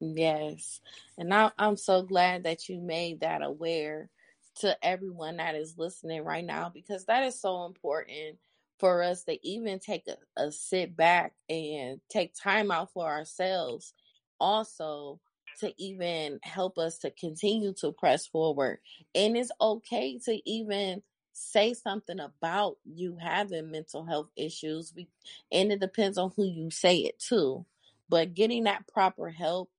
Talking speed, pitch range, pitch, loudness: 155 wpm, 160-200 Hz, 180 Hz, -30 LUFS